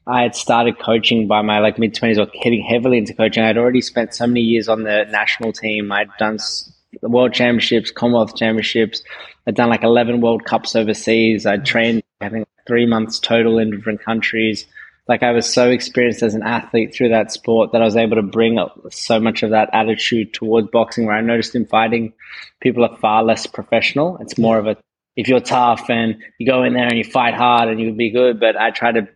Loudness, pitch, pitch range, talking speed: -16 LUFS, 115 Hz, 110-120 Hz, 215 wpm